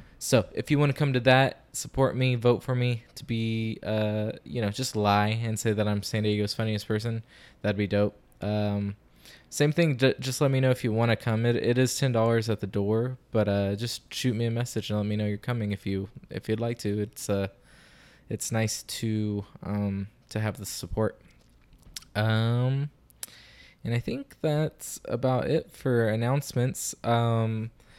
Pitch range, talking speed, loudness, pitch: 105-125 Hz, 195 wpm, -28 LUFS, 115 Hz